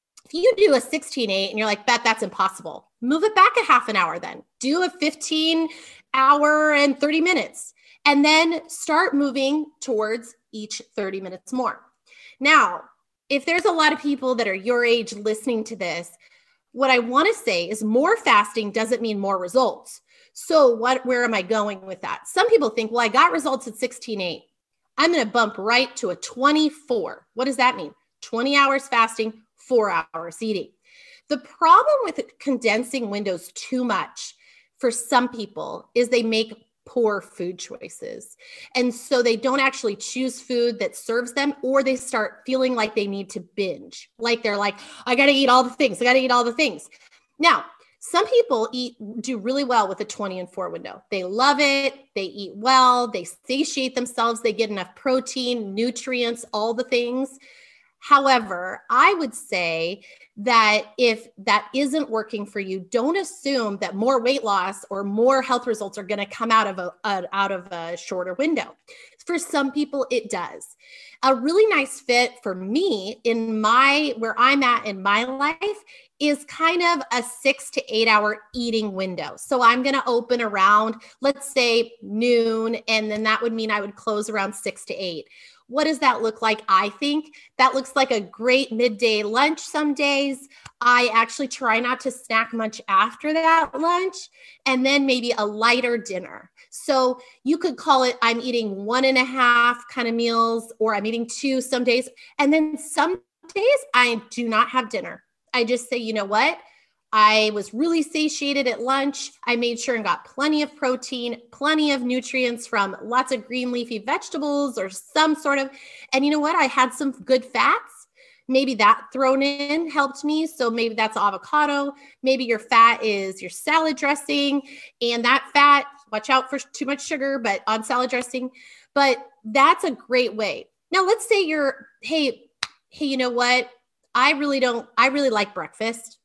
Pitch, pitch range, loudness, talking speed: 250 Hz, 225-285 Hz, -21 LUFS, 185 wpm